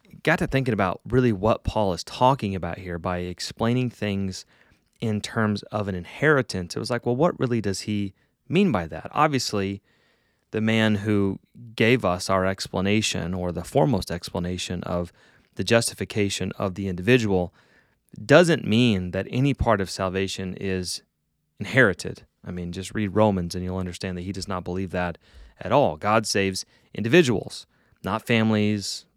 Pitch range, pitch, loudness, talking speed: 95-115 Hz, 100 Hz, -24 LUFS, 160 wpm